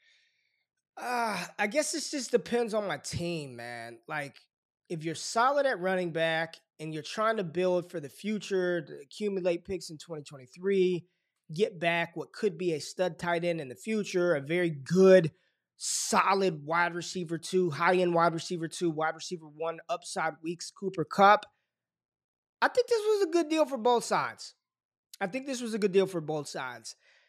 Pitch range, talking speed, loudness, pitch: 165-215 Hz, 180 wpm, -29 LUFS, 180 Hz